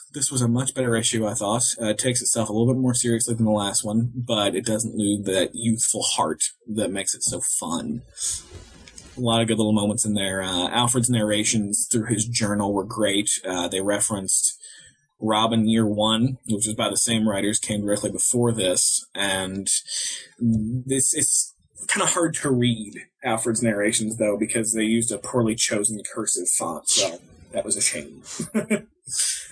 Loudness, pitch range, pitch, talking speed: -22 LUFS, 105-120 Hz, 110 Hz, 180 wpm